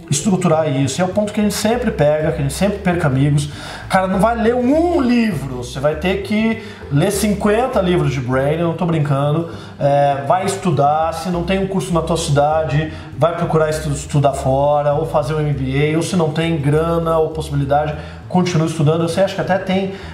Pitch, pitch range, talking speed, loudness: 160 Hz, 145-190 Hz, 205 wpm, -17 LUFS